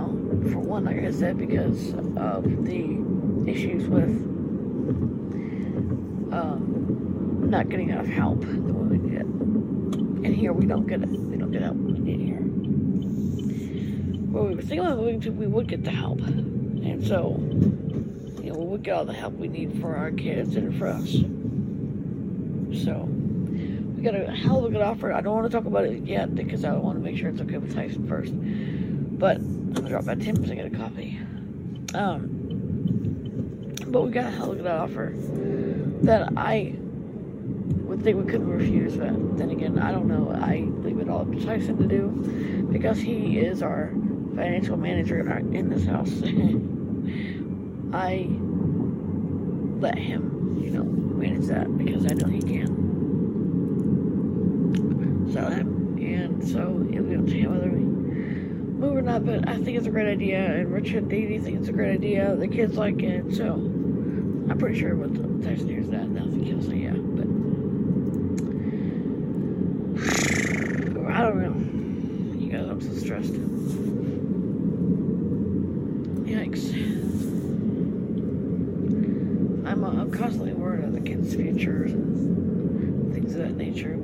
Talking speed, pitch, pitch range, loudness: 155 wpm, 210 Hz, 200-220 Hz, -26 LUFS